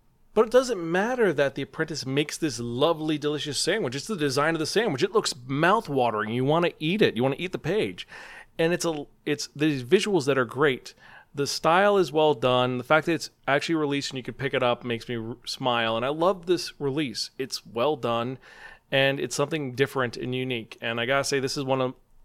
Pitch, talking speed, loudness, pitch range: 140 Hz, 230 wpm, -25 LUFS, 125-160 Hz